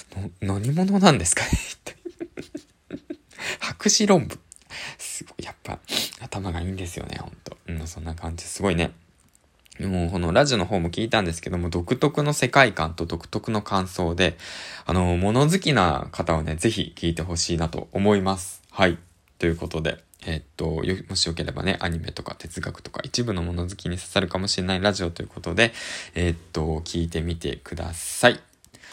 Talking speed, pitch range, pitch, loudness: 340 characters per minute, 85-105 Hz, 90 Hz, -24 LUFS